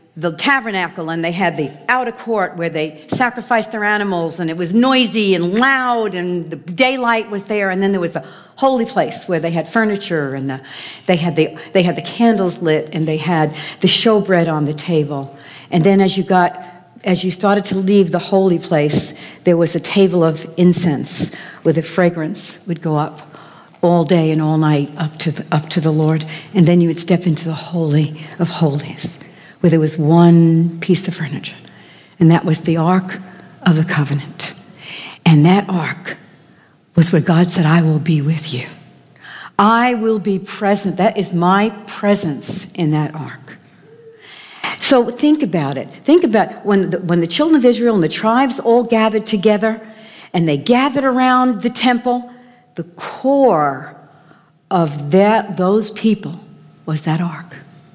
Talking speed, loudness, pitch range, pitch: 180 wpm, -15 LUFS, 160-205 Hz, 175 Hz